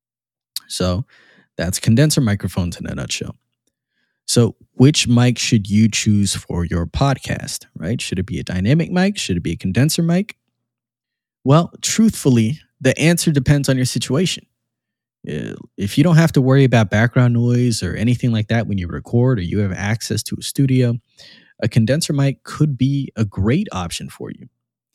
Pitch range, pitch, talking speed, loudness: 110-140 Hz, 120 Hz, 170 wpm, -18 LUFS